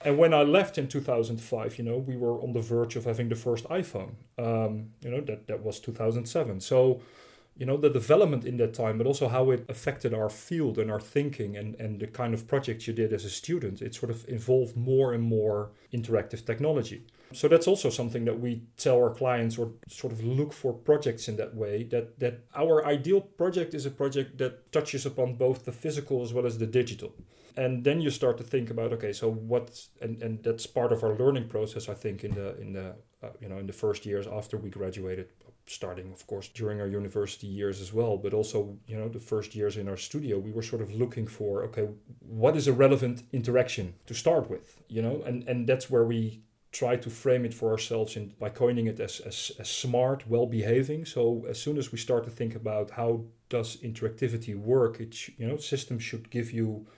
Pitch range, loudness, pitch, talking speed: 110-130 Hz, -29 LUFS, 120 Hz, 225 wpm